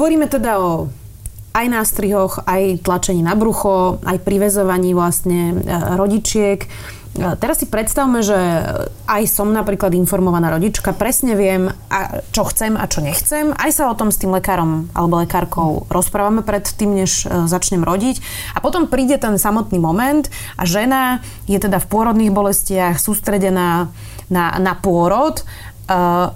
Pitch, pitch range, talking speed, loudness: 195 Hz, 175-215 Hz, 140 wpm, -16 LUFS